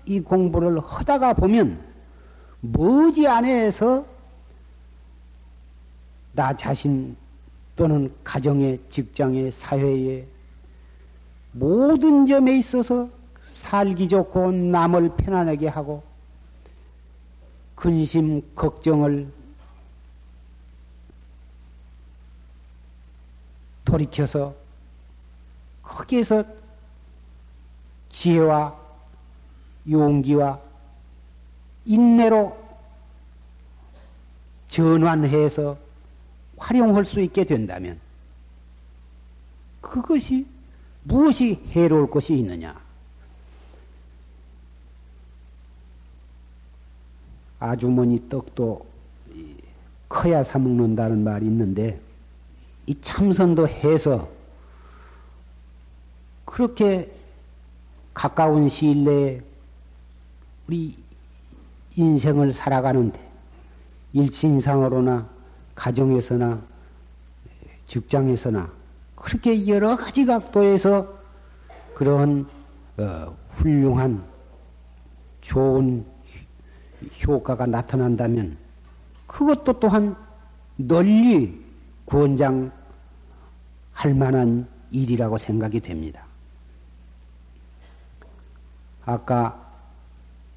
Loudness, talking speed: -21 LUFS, 140 characters per minute